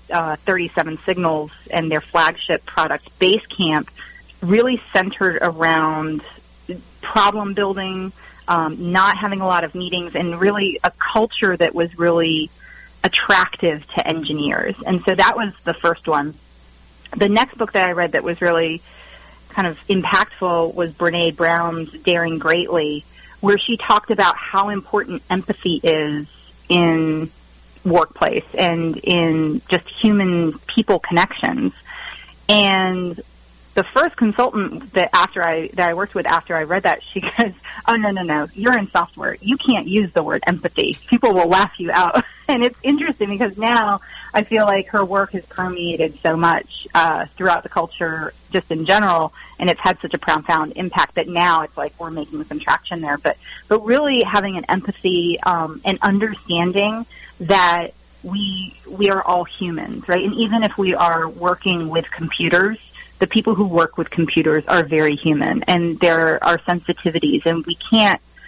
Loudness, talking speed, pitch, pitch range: -18 LUFS, 160 wpm, 175 Hz, 165-200 Hz